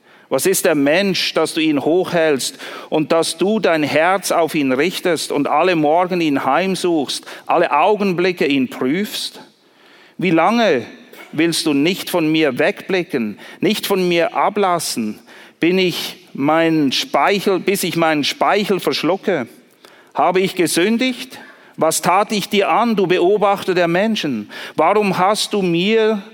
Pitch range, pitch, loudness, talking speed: 160-200 Hz, 185 Hz, -17 LUFS, 140 wpm